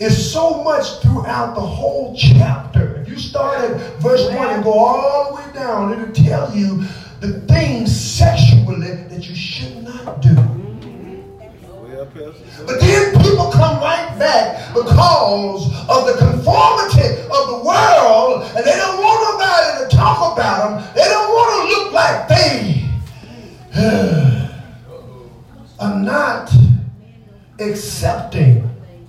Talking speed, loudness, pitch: 130 wpm, -14 LUFS, 165 Hz